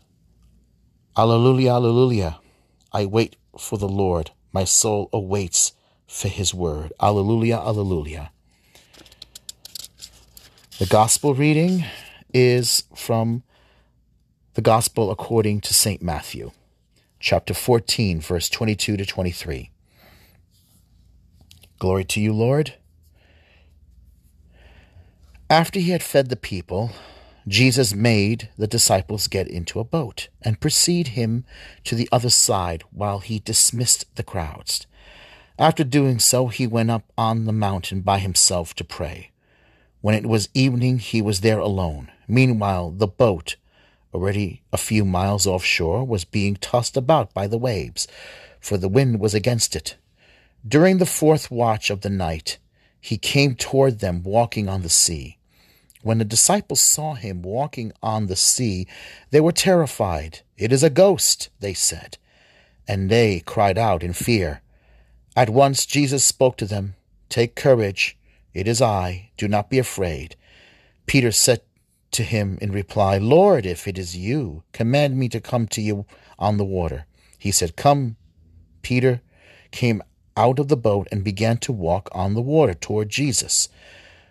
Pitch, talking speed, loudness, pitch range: 105 Hz, 140 wpm, -20 LUFS, 90-120 Hz